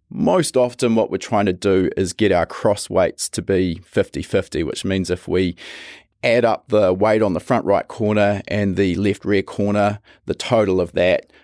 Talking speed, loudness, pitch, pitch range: 200 wpm, -19 LUFS, 100 Hz, 95-105 Hz